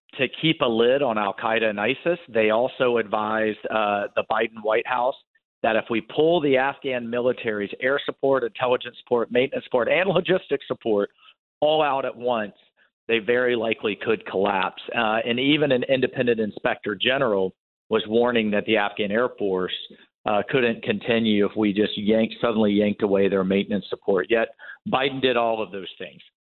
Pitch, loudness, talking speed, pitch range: 115 Hz, -23 LUFS, 175 wpm, 105-130 Hz